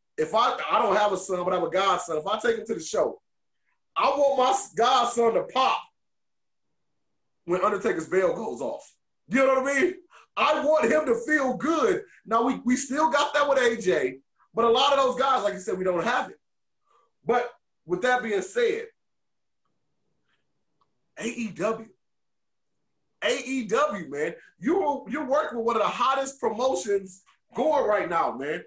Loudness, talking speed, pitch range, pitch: -25 LUFS, 175 wpm, 215-295 Hz, 255 Hz